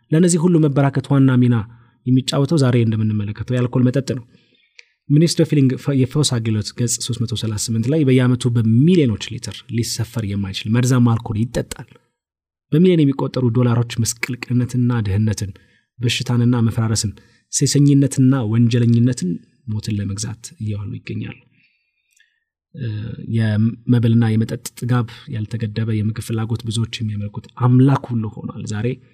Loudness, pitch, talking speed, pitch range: -18 LUFS, 120 Hz, 100 wpm, 110-130 Hz